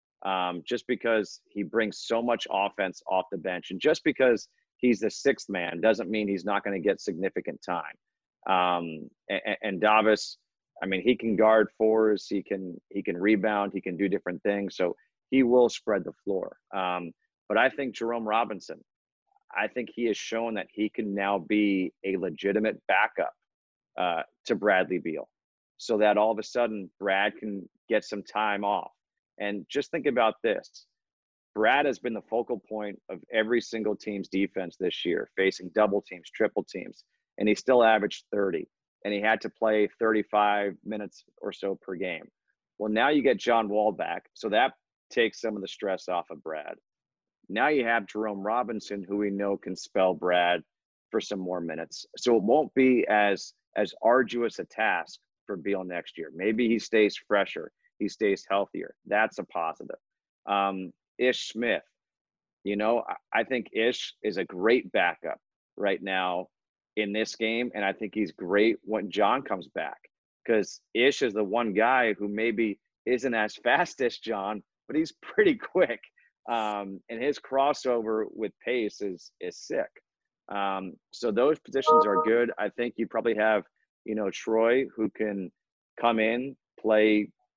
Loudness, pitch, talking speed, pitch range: -28 LUFS, 105 Hz, 175 wpm, 100-115 Hz